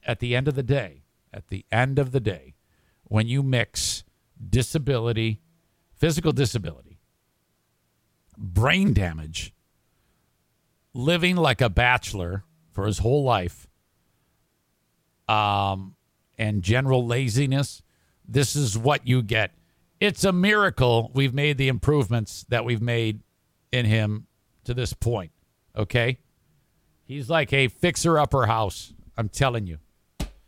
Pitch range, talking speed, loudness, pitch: 100-135 Hz, 125 wpm, -24 LUFS, 120 Hz